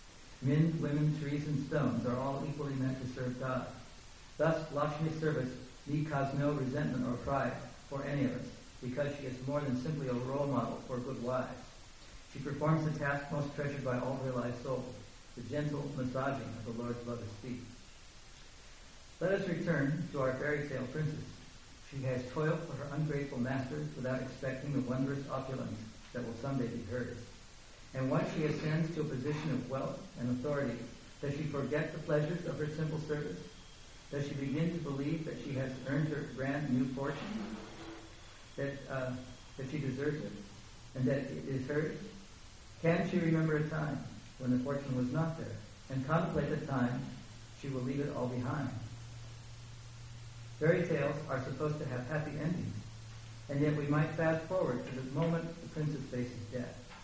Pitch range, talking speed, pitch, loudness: 125-150 Hz, 175 wpm, 135 Hz, -37 LUFS